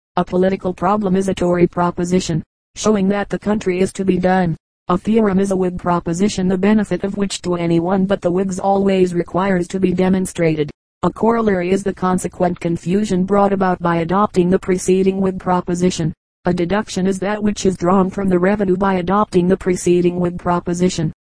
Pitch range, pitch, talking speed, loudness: 175-195 Hz, 185 Hz, 185 wpm, -17 LUFS